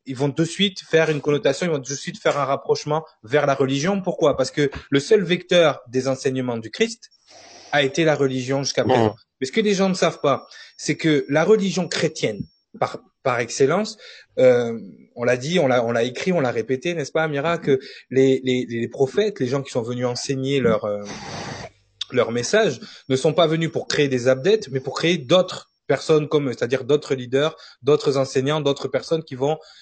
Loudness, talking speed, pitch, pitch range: -21 LUFS, 205 wpm, 145 Hz, 130-170 Hz